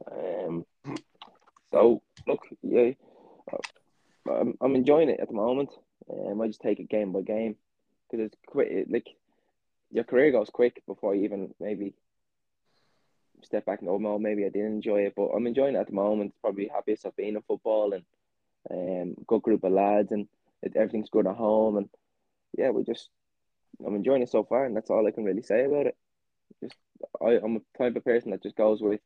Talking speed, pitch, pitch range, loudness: 195 wpm, 105 Hz, 100-110 Hz, -28 LUFS